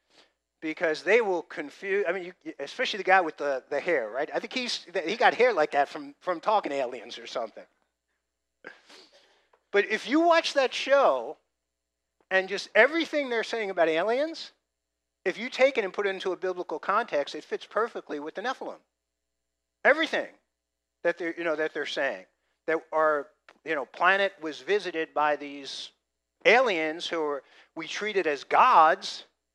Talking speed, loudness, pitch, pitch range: 170 wpm, -26 LUFS, 165 Hz, 140-210 Hz